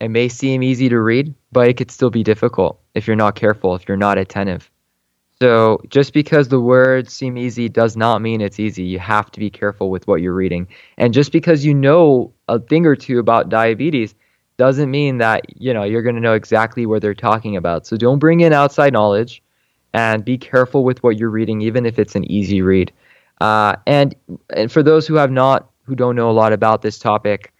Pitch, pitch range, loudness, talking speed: 115 Hz, 105-130 Hz, -15 LUFS, 220 wpm